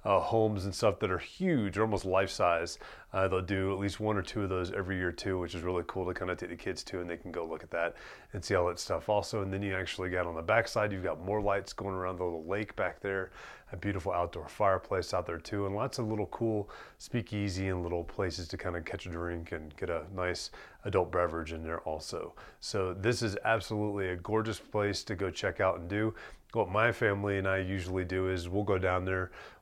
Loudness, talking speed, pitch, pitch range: -33 LUFS, 245 wpm, 95 Hz, 90-105 Hz